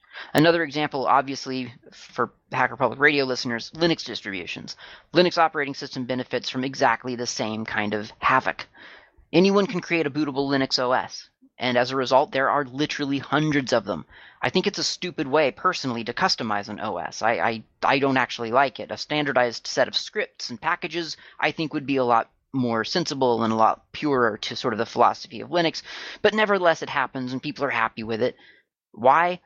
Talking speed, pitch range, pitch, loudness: 190 wpm, 120-155 Hz, 135 Hz, -24 LUFS